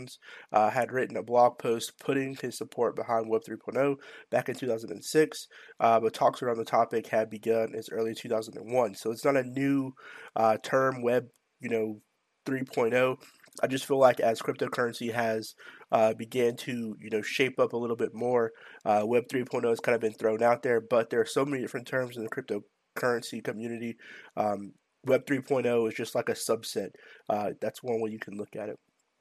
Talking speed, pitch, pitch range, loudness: 195 wpm, 120 Hz, 110-130 Hz, -29 LUFS